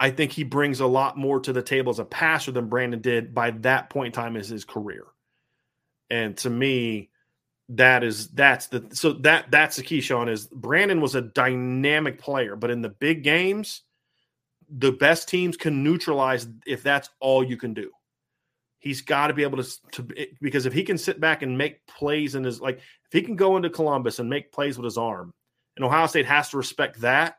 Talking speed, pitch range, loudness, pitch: 215 wpm, 125-145 Hz, -23 LUFS, 135 Hz